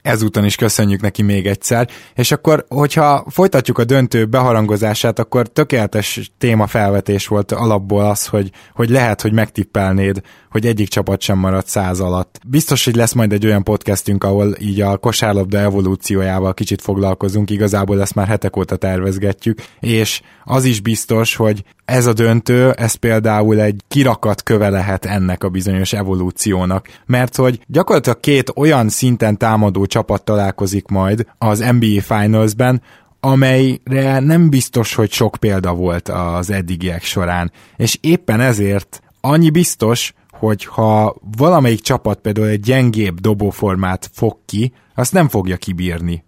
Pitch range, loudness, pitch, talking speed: 100-120 Hz, -15 LUFS, 105 Hz, 145 wpm